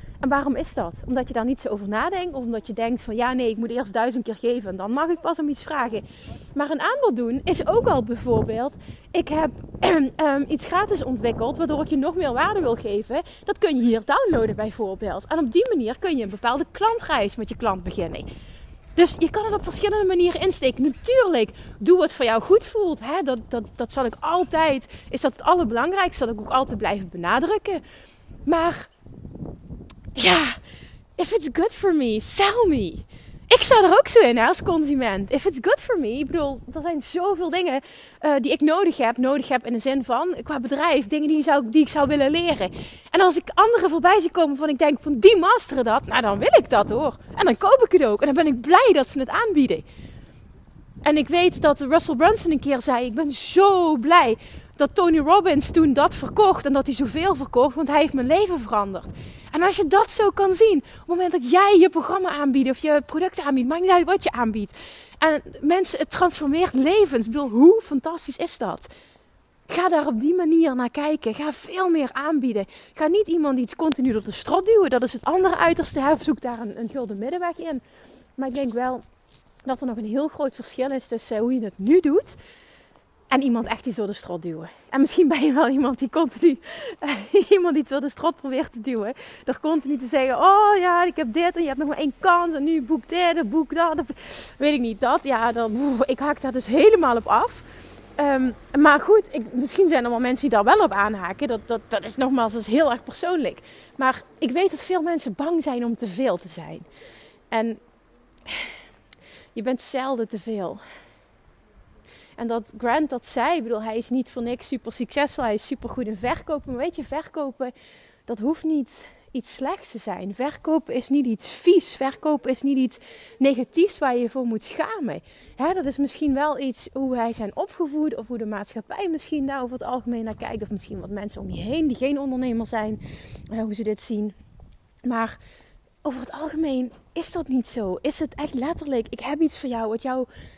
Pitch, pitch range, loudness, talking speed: 285 Hz, 245-335 Hz, -21 LUFS, 220 wpm